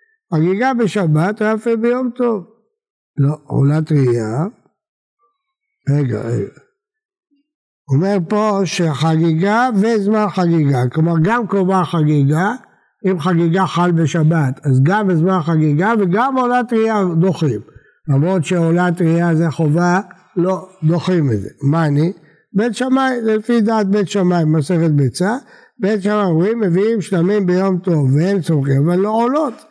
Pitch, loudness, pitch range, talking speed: 185 Hz, -16 LUFS, 160-220 Hz, 125 wpm